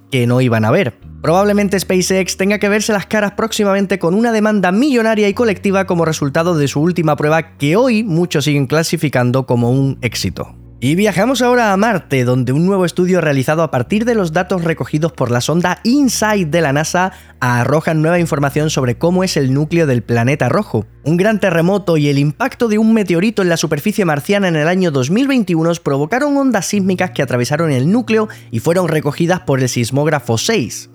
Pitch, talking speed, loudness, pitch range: 170 Hz, 190 wpm, -14 LUFS, 140-200 Hz